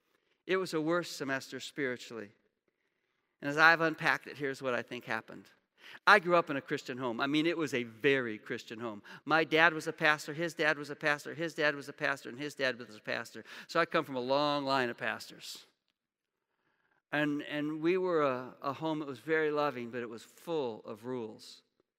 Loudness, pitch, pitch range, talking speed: -32 LUFS, 145 Hz, 125-160 Hz, 215 wpm